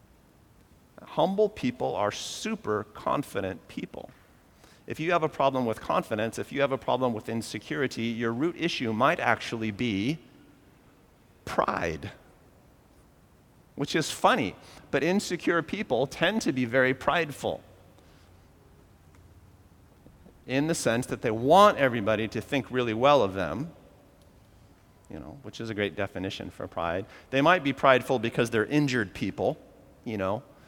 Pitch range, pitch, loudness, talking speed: 100-135 Hz, 115 Hz, -27 LUFS, 135 wpm